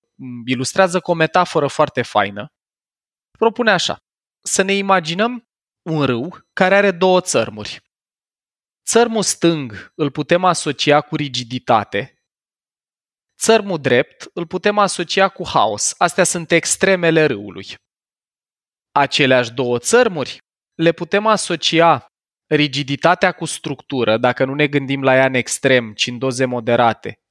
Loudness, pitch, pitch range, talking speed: -16 LUFS, 160 Hz, 130-185 Hz, 125 wpm